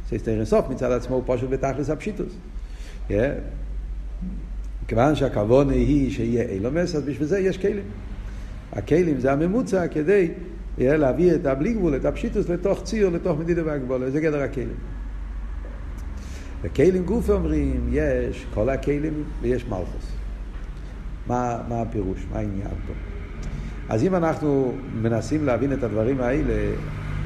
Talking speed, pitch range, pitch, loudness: 130 wpm, 100-155 Hz, 130 Hz, -24 LUFS